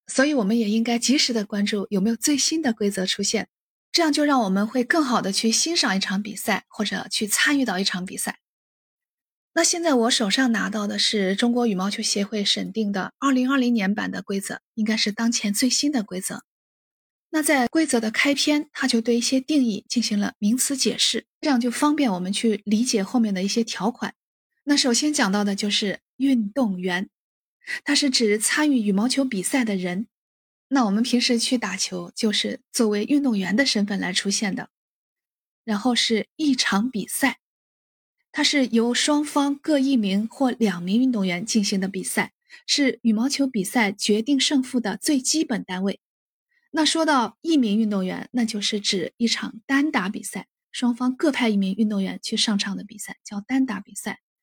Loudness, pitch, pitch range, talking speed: -22 LUFS, 230 Hz, 205-270 Hz, 270 characters per minute